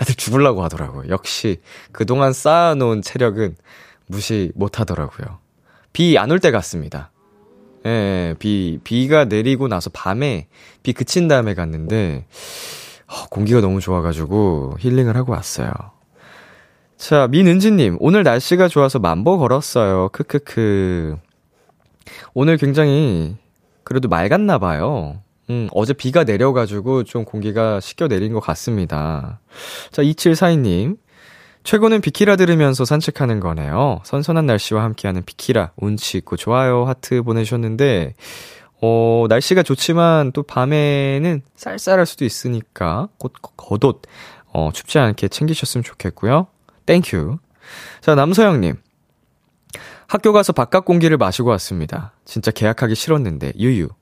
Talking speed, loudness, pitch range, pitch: 280 characters per minute, -17 LUFS, 100-145 Hz, 120 Hz